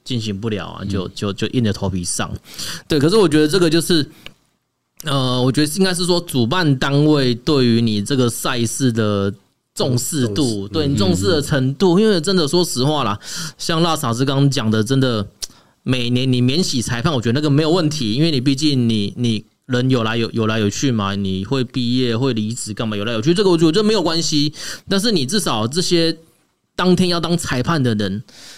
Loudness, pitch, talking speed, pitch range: -18 LUFS, 130 Hz, 295 characters per minute, 110-160 Hz